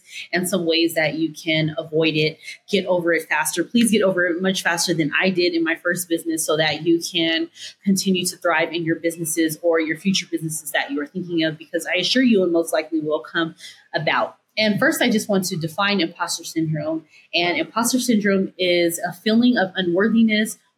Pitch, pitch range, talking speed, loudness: 170 Hz, 160-190 Hz, 205 wpm, -20 LUFS